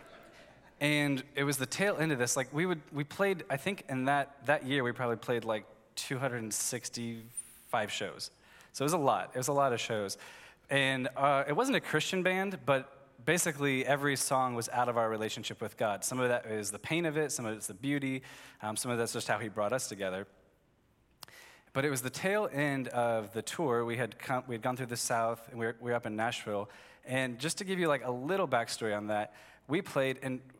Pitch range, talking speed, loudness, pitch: 115-145 Hz, 230 wpm, -33 LUFS, 130 Hz